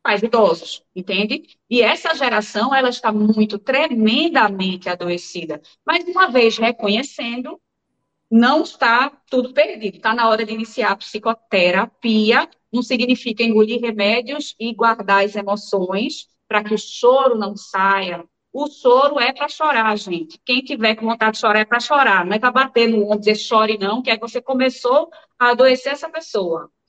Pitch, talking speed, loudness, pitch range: 230 Hz, 165 wpm, -17 LUFS, 210-260 Hz